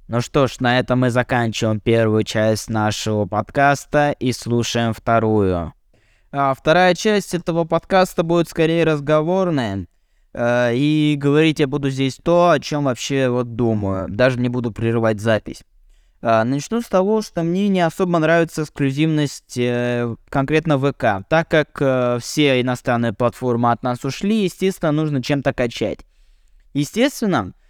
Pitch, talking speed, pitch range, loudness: 135 Hz, 145 wpm, 120-155 Hz, -19 LUFS